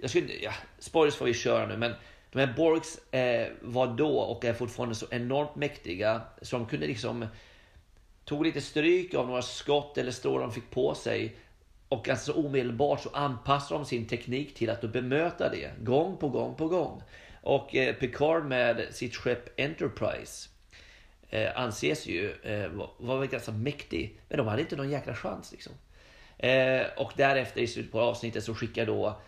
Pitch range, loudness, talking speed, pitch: 115-145 Hz, -30 LUFS, 180 wpm, 125 Hz